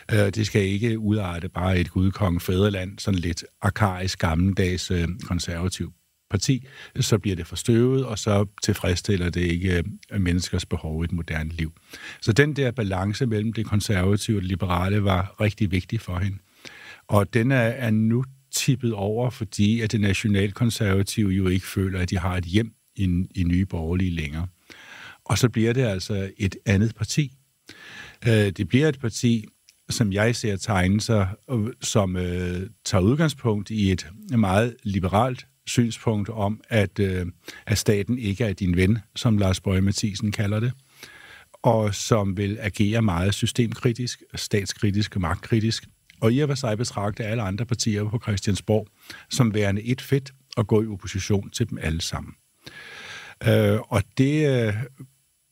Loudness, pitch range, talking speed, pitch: -24 LUFS, 95-115 Hz, 155 wpm, 105 Hz